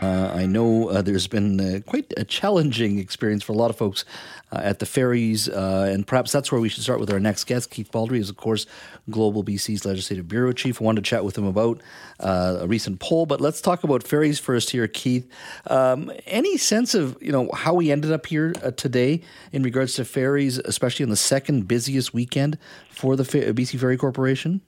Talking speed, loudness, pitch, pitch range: 220 wpm, -23 LUFS, 125 Hz, 105-140 Hz